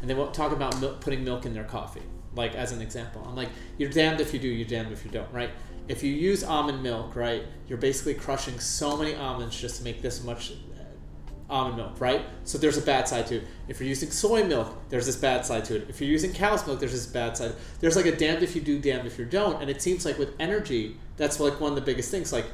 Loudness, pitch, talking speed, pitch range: -28 LUFS, 130 Hz, 265 wpm, 115-145 Hz